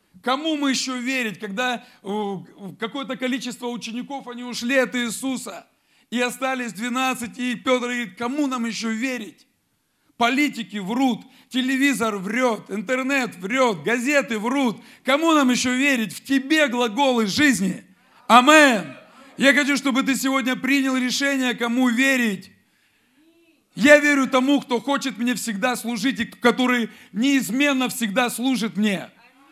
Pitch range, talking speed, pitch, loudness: 235-270 Hz, 125 wpm, 250 Hz, -21 LUFS